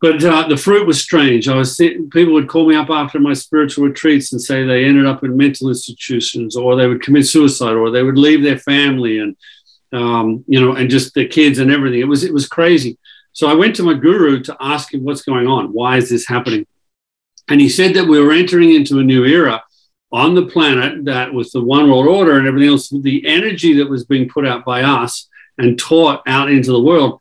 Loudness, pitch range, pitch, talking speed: -12 LUFS, 125-155 Hz, 140 Hz, 235 wpm